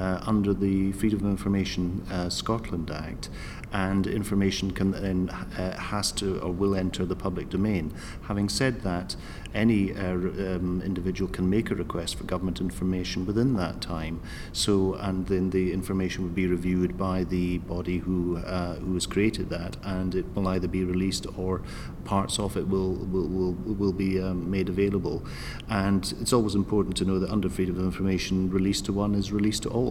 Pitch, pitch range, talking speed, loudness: 95 Hz, 90-100 Hz, 185 wpm, -28 LUFS